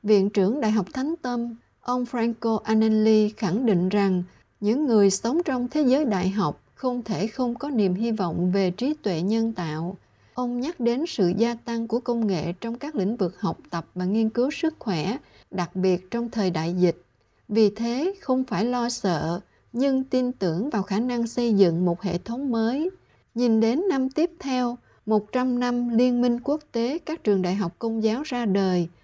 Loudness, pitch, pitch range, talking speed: -25 LUFS, 225 Hz, 190-250 Hz, 195 wpm